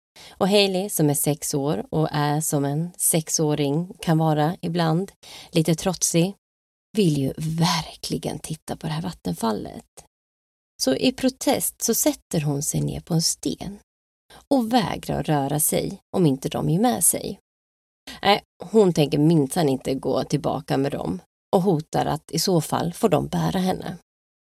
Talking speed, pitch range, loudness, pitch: 155 wpm, 145-185 Hz, -23 LUFS, 160 Hz